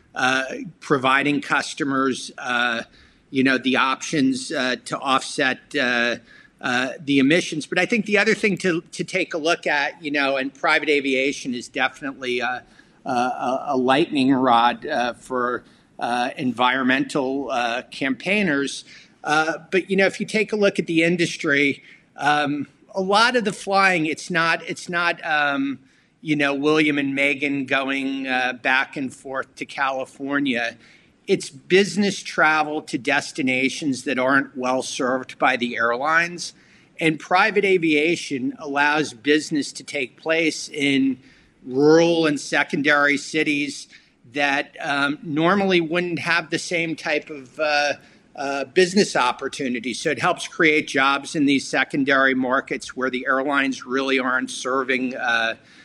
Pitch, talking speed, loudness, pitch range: 145 Hz, 145 wpm, -21 LUFS, 135-170 Hz